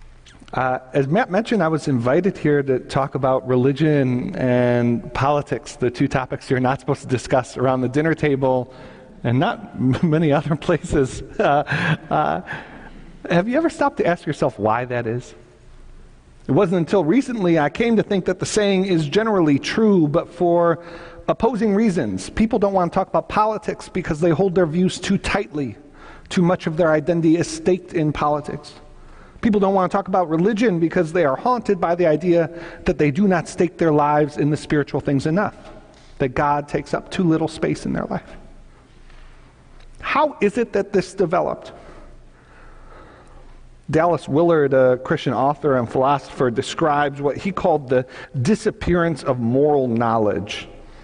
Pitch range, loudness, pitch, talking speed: 135-185 Hz, -20 LUFS, 160 Hz, 165 wpm